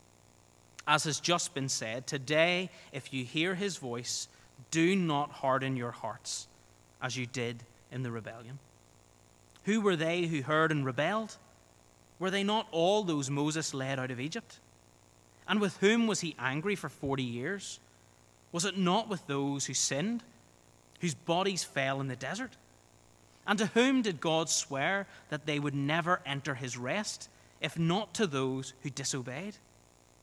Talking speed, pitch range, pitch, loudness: 160 wpm, 130-180 Hz, 145 Hz, -32 LUFS